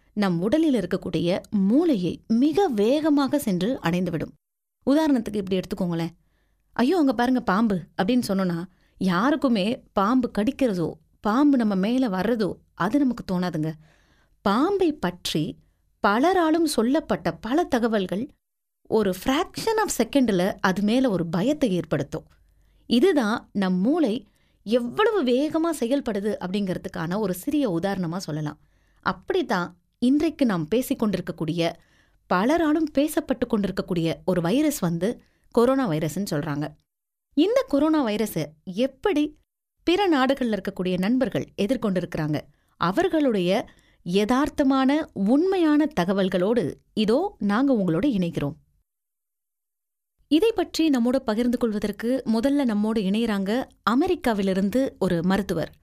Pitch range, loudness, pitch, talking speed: 185-275 Hz, -24 LUFS, 225 Hz, 100 wpm